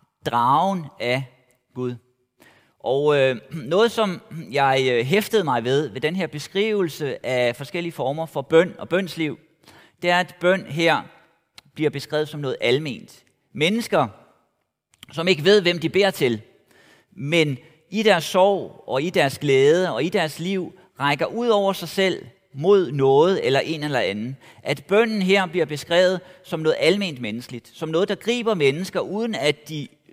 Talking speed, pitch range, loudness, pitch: 155 wpm, 140-190 Hz, -21 LUFS, 165 Hz